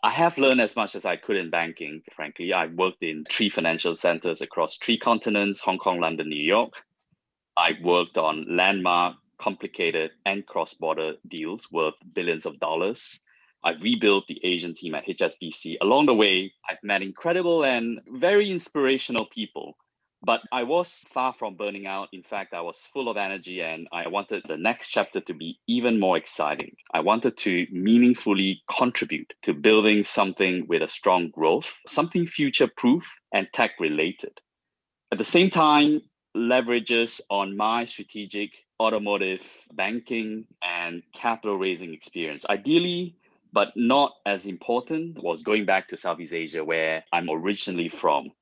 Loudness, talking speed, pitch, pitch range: -25 LUFS, 155 wpm, 105 Hz, 90-120 Hz